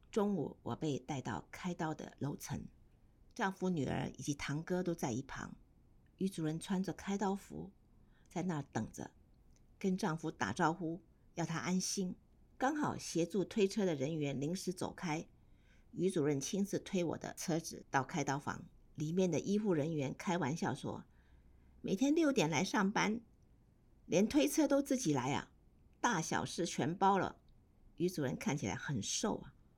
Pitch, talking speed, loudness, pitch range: 170 Hz, 230 characters per minute, -38 LUFS, 145-195 Hz